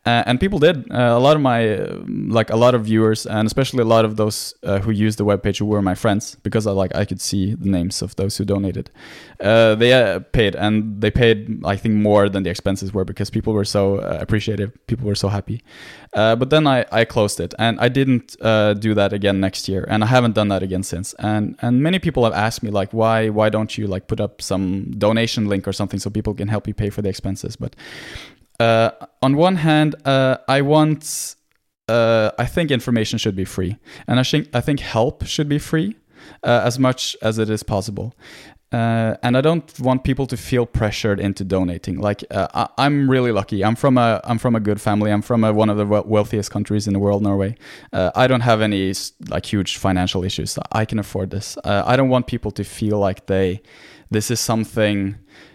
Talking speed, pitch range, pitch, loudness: 225 wpm, 100-120 Hz, 110 Hz, -19 LUFS